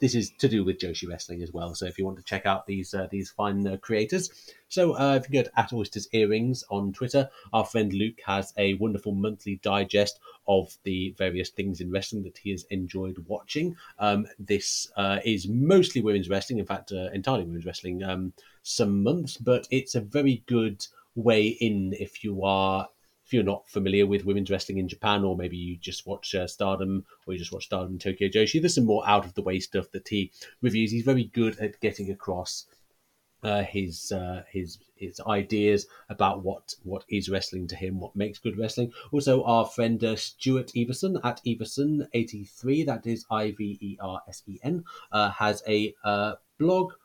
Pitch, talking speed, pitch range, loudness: 105 Hz, 195 wpm, 95-115 Hz, -28 LUFS